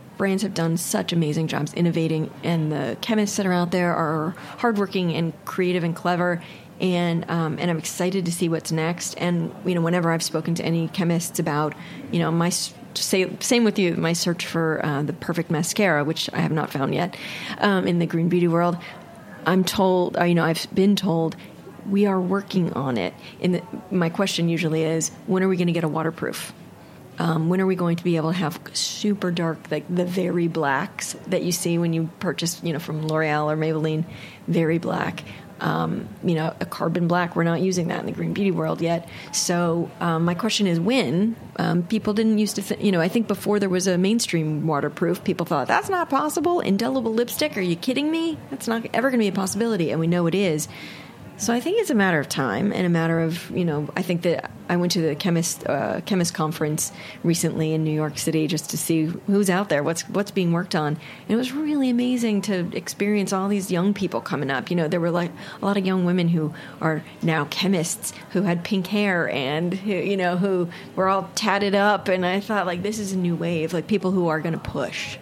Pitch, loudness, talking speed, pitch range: 175 Hz, -23 LUFS, 225 wpm, 165-195 Hz